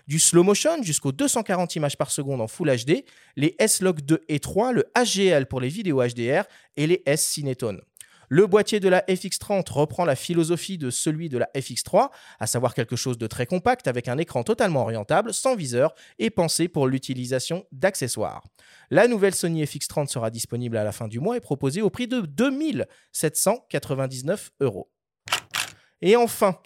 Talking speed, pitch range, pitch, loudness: 175 wpm, 130-195 Hz, 155 Hz, -23 LUFS